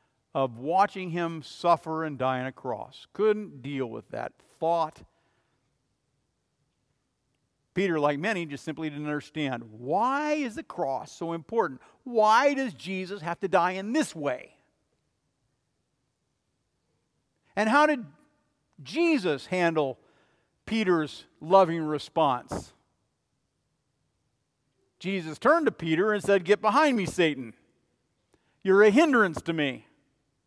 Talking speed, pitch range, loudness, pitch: 115 wpm, 145-210 Hz, -27 LUFS, 170 Hz